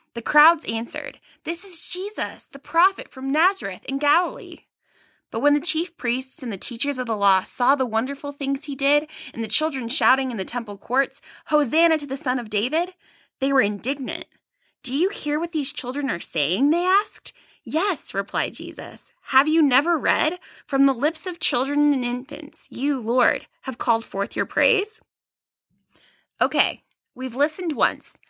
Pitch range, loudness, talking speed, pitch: 250-315 Hz, -22 LUFS, 170 wpm, 280 Hz